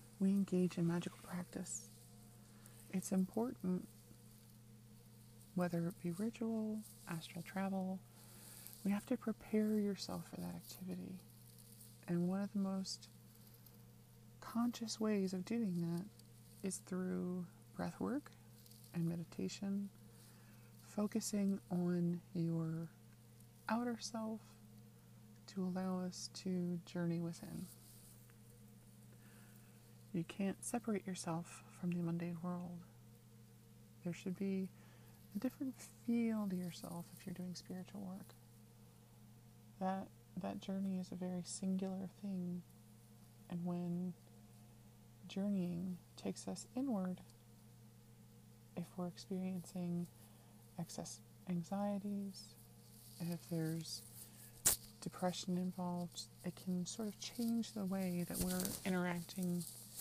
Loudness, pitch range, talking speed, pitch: -43 LUFS, 115-190 Hz, 100 wpm, 170 Hz